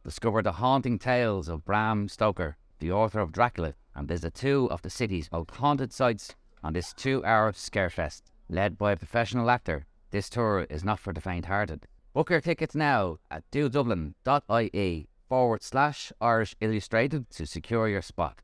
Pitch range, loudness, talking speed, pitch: 85-120 Hz, -28 LUFS, 165 wpm, 105 Hz